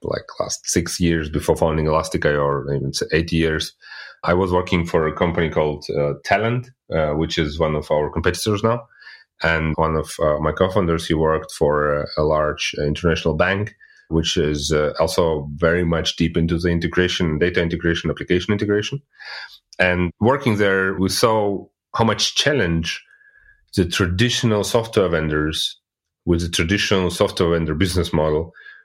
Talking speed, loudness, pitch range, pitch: 160 wpm, -20 LUFS, 80-95 Hz, 85 Hz